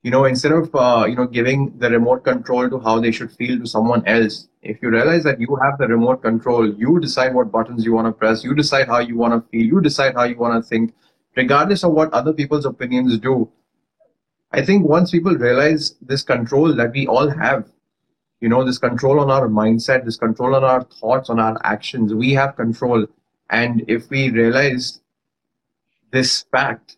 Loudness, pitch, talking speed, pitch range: -17 LUFS, 125 Hz, 205 wpm, 115-135 Hz